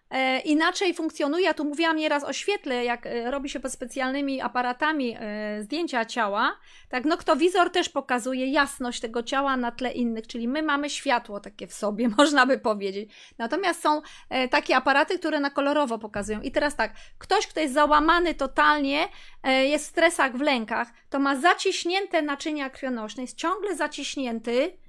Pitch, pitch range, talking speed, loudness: 280 Hz, 245-310 Hz, 160 wpm, -25 LUFS